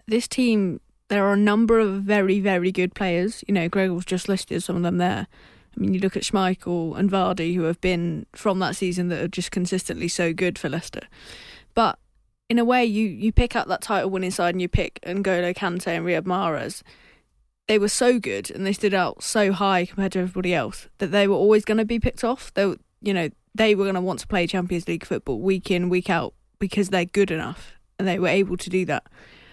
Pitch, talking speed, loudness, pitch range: 190 Hz, 230 wpm, -23 LUFS, 180-200 Hz